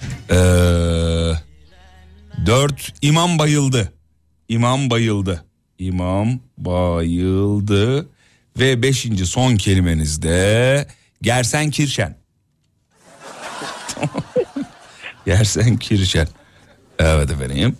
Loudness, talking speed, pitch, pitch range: -18 LUFS, 65 wpm, 105 Hz, 85-125 Hz